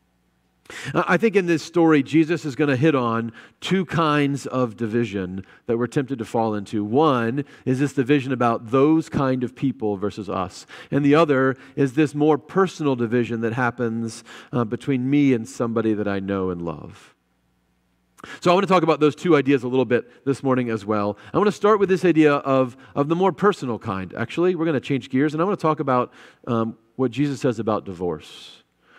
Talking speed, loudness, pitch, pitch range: 205 wpm, -21 LUFS, 130 Hz, 115-150 Hz